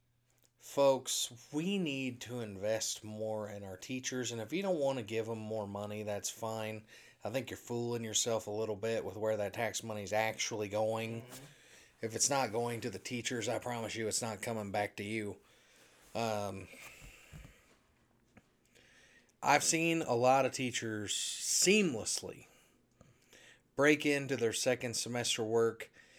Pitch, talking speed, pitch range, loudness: 115 Hz, 150 wpm, 110-125 Hz, -35 LUFS